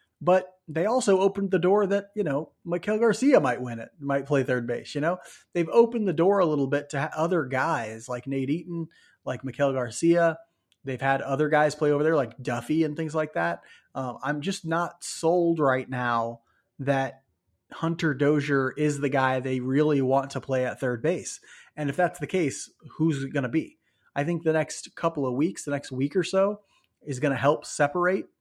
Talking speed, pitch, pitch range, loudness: 205 wpm, 150 Hz, 135-170 Hz, -26 LUFS